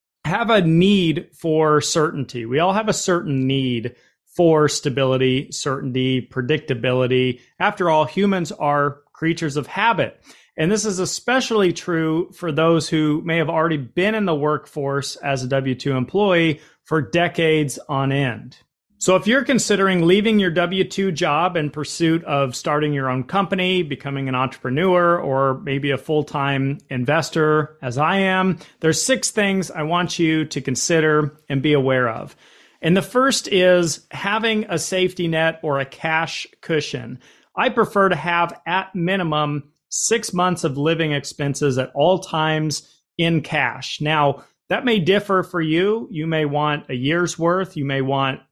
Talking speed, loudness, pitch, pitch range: 160 wpm, -20 LUFS, 160 Hz, 140-180 Hz